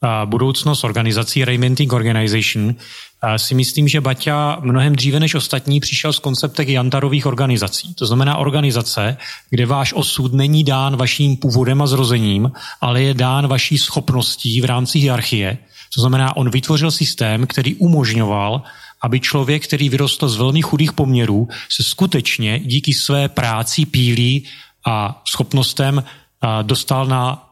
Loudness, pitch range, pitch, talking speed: -16 LUFS, 125-145 Hz, 135 Hz, 140 wpm